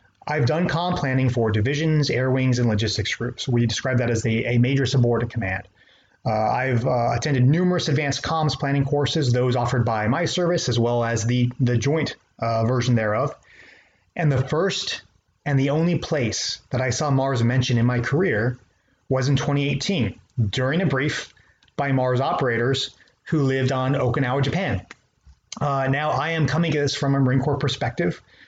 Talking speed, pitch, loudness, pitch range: 175 wpm, 130 Hz, -22 LUFS, 120-145 Hz